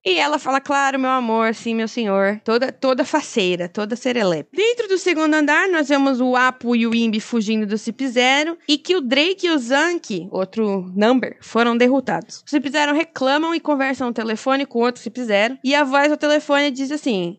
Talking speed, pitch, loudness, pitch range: 205 wpm, 260 Hz, -19 LUFS, 225-295 Hz